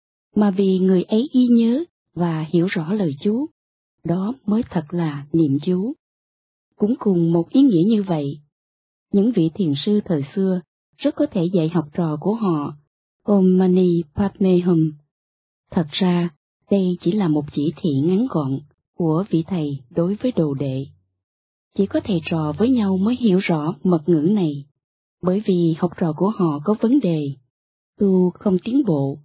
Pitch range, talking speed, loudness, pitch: 155-200 Hz, 170 wpm, -20 LUFS, 175 Hz